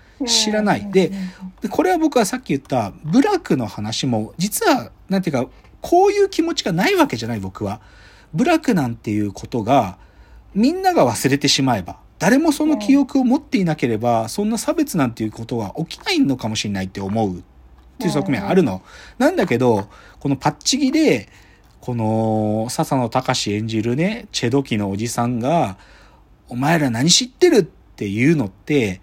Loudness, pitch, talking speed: -19 LUFS, 140 Hz, 350 characters per minute